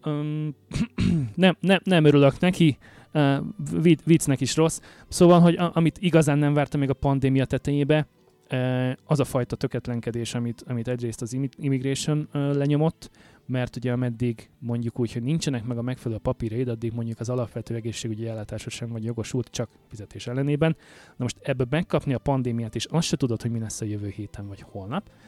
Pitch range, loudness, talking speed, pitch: 115-150 Hz, -25 LUFS, 175 wpm, 130 Hz